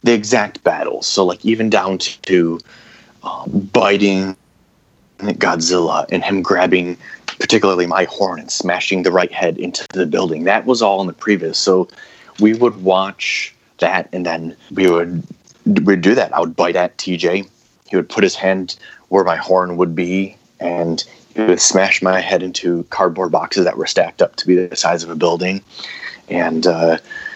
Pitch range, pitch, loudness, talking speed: 90-100 Hz, 95 Hz, -16 LUFS, 175 wpm